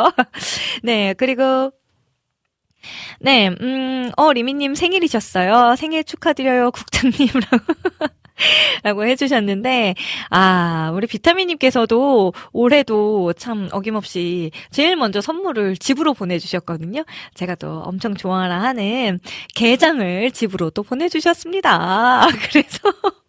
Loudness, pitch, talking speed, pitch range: -17 LUFS, 245 Hz, 245 characters per minute, 200-285 Hz